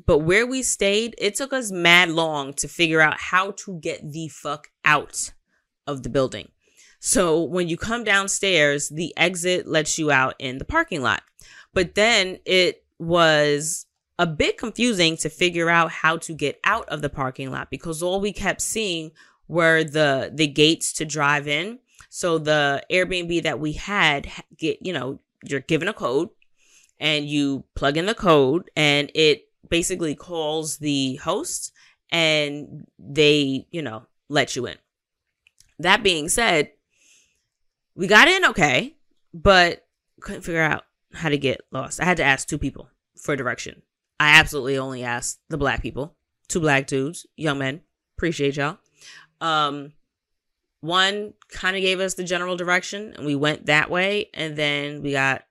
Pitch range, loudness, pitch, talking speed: 145-180 Hz, -21 LUFS, 160 Hz, 165 wpm